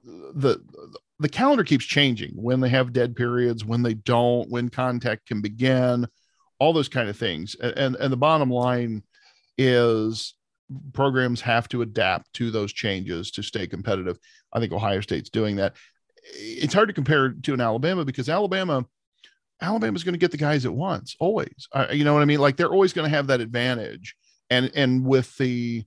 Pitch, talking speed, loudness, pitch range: 125 Hz, 190 wpm, -23 LUFS, 115-145 Hz